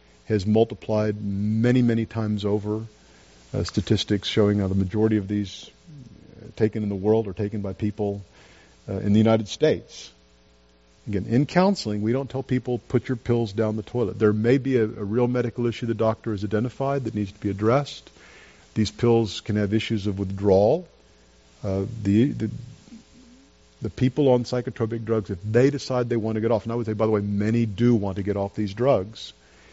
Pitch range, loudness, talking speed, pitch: 100-115 Hz, -24 LUFS, 190 wpm, 110 Hz